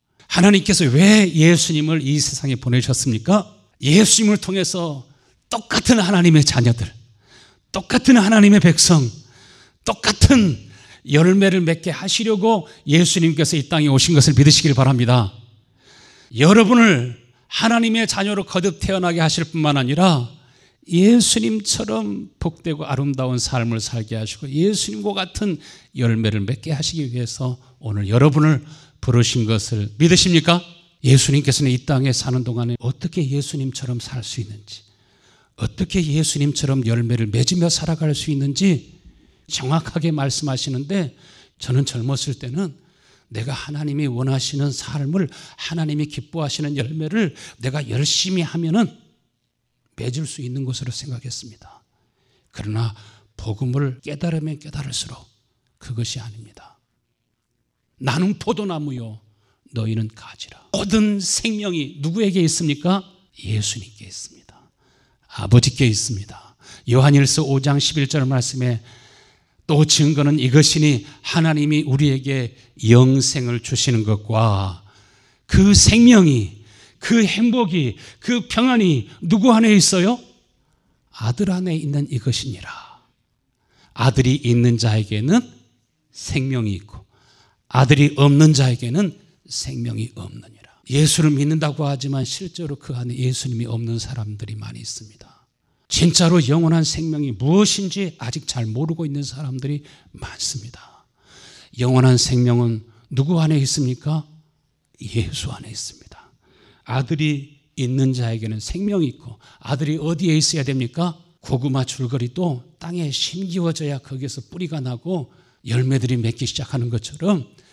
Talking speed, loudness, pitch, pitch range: 290 characters per minute, -18 LUFS, 140 Hz, 125-165 Hz